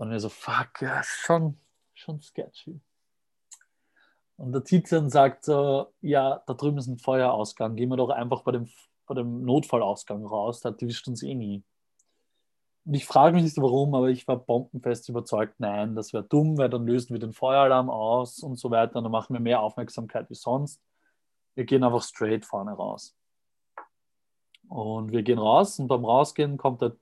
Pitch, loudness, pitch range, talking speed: 125 Hz, -26 LUFS, 115-140 Hz, 180 wpm